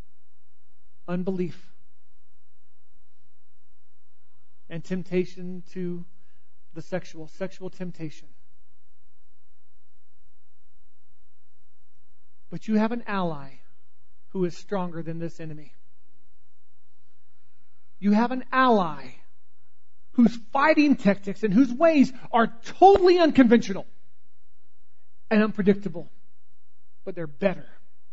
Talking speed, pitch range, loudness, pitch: 80 wpm, 125-195 Hz, -23 LUFS, 150 Hz